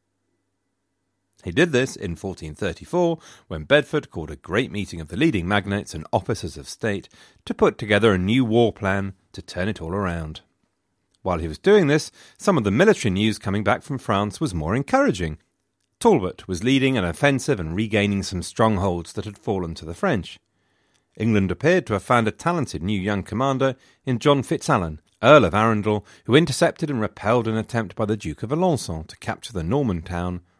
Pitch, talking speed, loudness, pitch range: 105 Hz, 185 wpm, -22 LUFS, 90-125 Hz